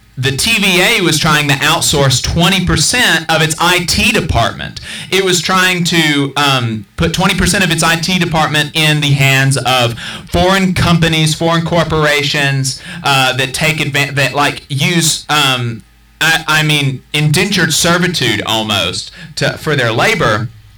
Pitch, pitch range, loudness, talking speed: 155 Hz, 135-170 Hz, -11 LUFS, 140 wpm